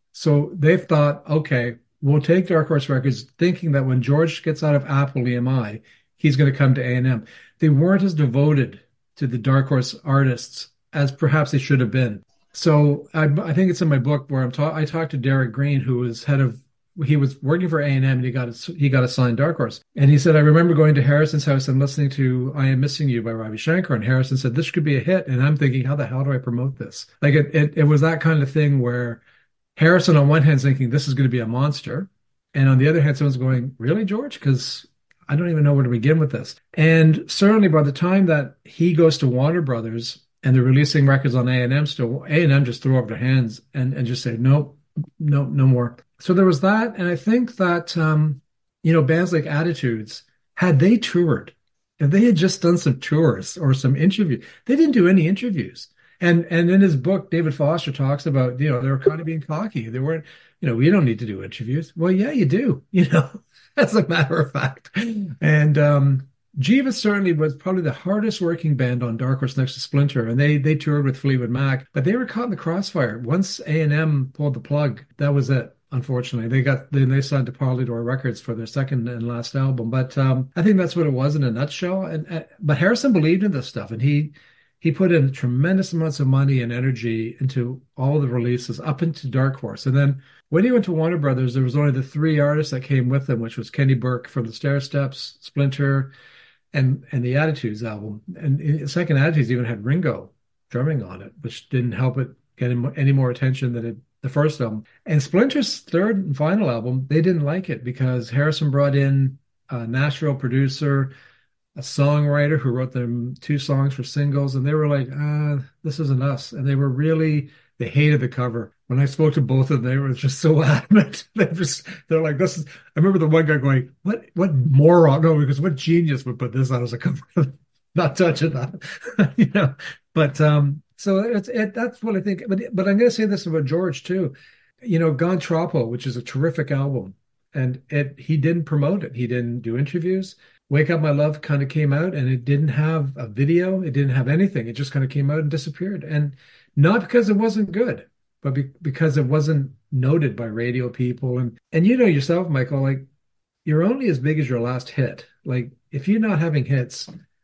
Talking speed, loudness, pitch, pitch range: 225 wpm, -20 LUFS, 145 Hz, 130-160 Hz